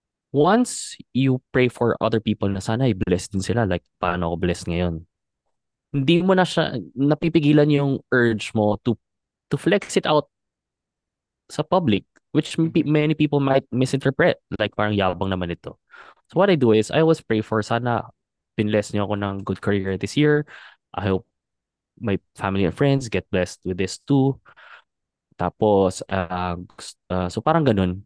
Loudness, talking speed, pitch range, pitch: -22 LUFS, 165 wpm, 95-140 Hz, 110 Hz